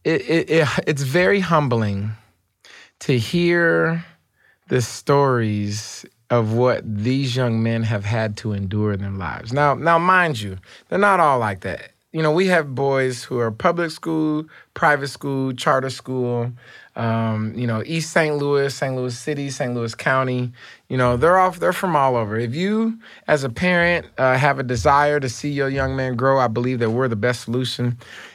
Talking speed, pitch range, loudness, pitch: 180 wpm, 115-150 Hz, -20 LUFS, 130 Hz